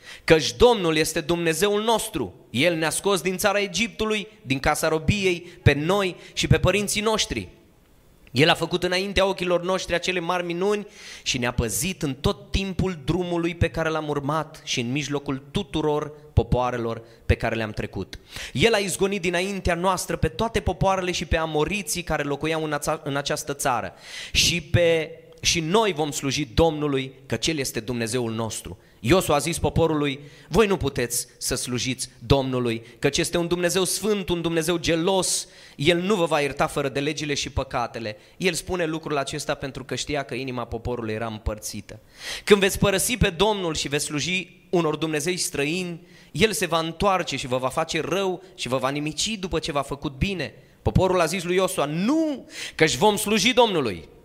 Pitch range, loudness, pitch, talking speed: 135-185 Hz, -24 LUFS, 160 Hz, 175 wpm